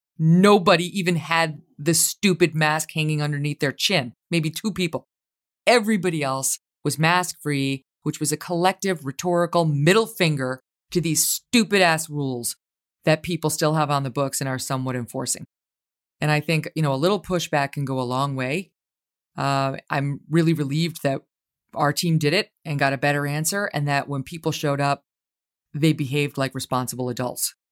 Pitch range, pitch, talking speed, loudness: 135-170 Hz, 150 Hz, 165 wpm, -22 LUFS